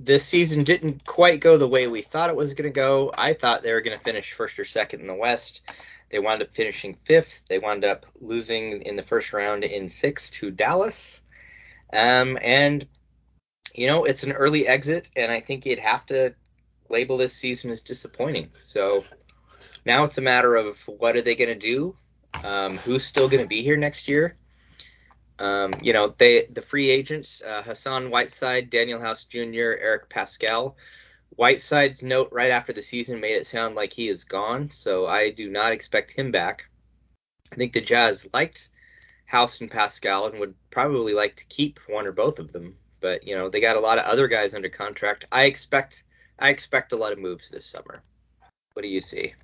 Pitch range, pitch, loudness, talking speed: 115-150 Hz, 130 Hz, -23 LUFS, 200 wpm